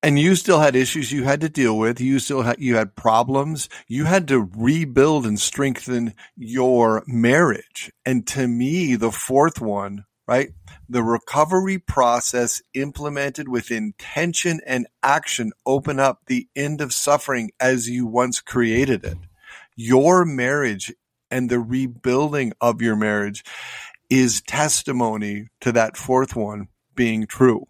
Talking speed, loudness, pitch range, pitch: 145 wpm, -20 LUFS, 115-140 Hz, 125 Hz